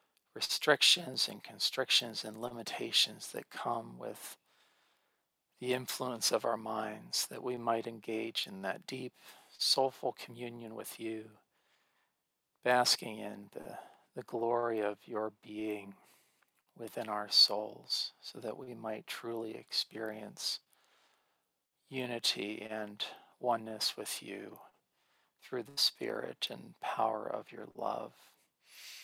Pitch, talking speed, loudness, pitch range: 115 Hz, 110 wpm, -34 LUFS, 110-120 Hz